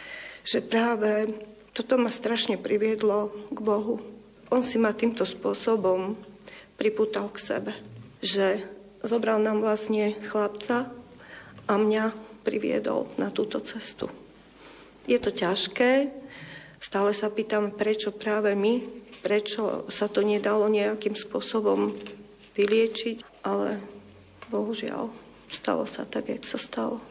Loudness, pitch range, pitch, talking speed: -27 LUFS, 205-225 Hz, 215 Hz, 115 wpm